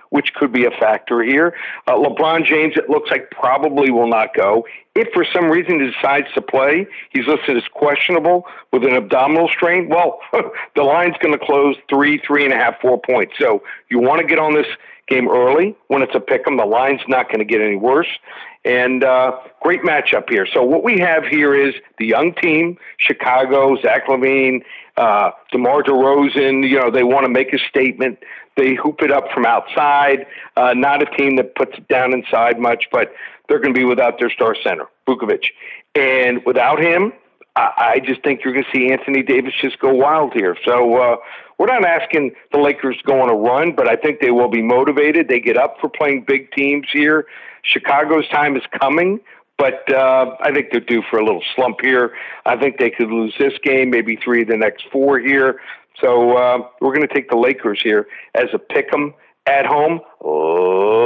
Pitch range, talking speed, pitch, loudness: 125-155 Hz, 205 wpm, 140 Hz, -15 LUFS